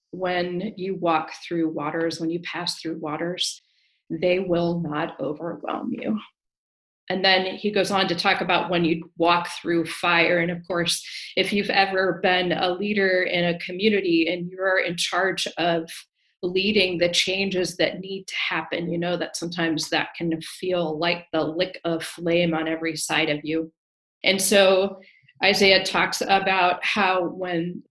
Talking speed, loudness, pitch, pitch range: 165 wpm, -23 LUFS, 175 Hz, 165-190 Hz